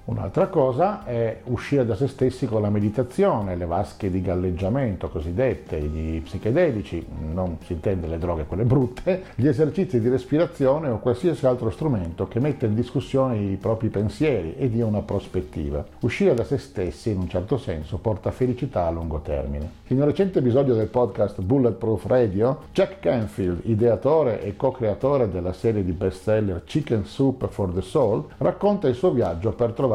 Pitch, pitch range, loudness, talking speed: 115 Hz, 95-130 Hz, -24 LUFS, 170 wpm